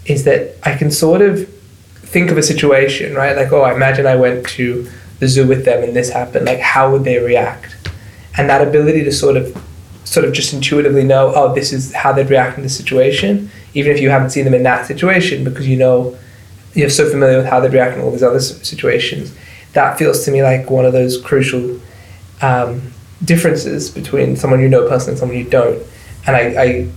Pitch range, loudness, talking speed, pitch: 125-140 Hz, -13 LUFS, 220 wpm, 130 Hz